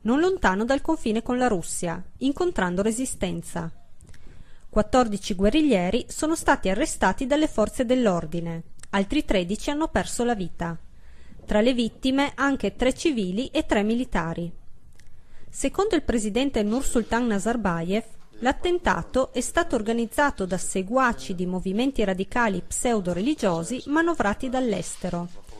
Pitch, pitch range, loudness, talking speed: 225 Hz, 190-265 Hz, -25 LUFS, 115 wpm